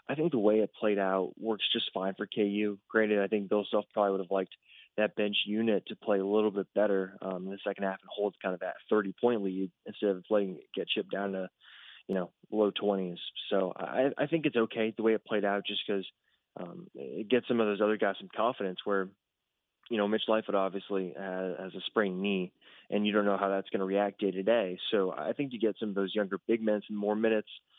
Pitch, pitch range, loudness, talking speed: 100 Hz, 95-105 Hz, -31 LUFS, 240 wpm